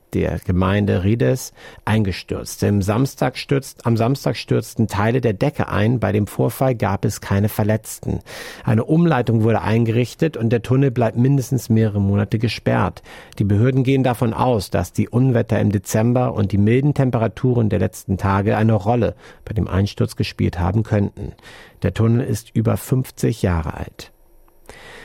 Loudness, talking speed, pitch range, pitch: -19 LUFS, 150 wpm, 100-125 Hz, 110 Hz